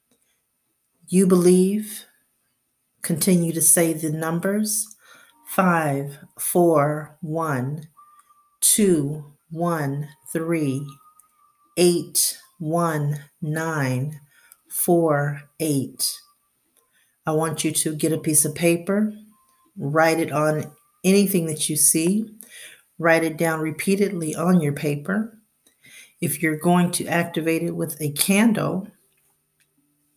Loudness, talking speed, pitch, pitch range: -21 LUFS, 100 wpm, 165 Hz, 150-190 Hz